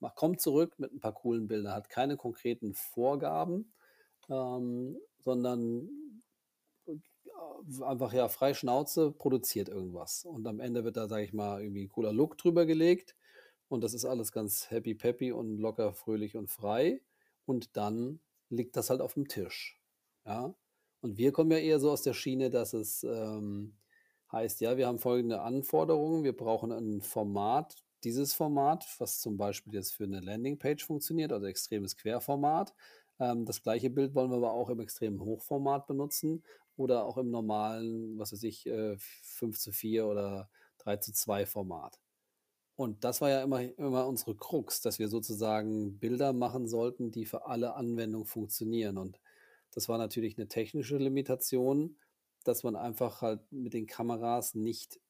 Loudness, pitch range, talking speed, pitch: -34 LUFS, 110-135 Hz, 165 wpm, 120 Hz